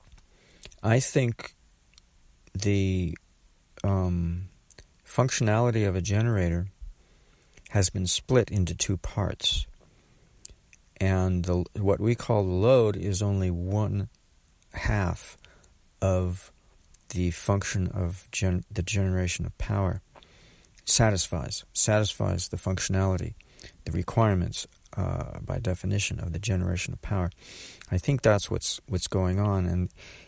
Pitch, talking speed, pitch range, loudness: 95 Hz, 110 wpm, 90-105 Hz, -27 LUFS